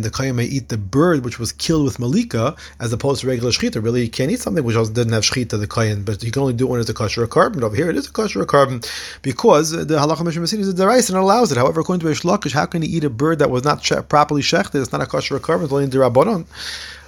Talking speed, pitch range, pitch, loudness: 295 wpm, 120-160 Hz, 135 Hz, -18 LUFS